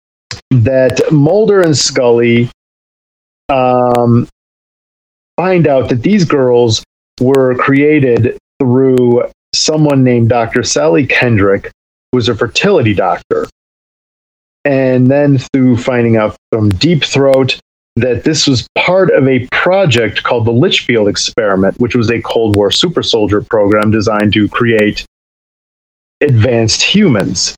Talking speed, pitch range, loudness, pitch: 120 wpm, 105-135 Hz, -10 LUFS, 125 Hz